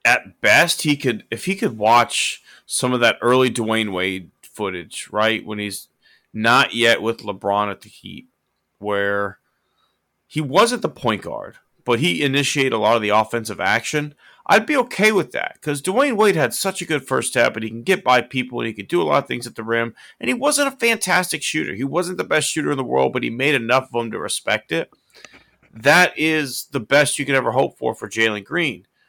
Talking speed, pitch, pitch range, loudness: 220 wpm, 125 Hz, 110-150 Hz, -19 LUFS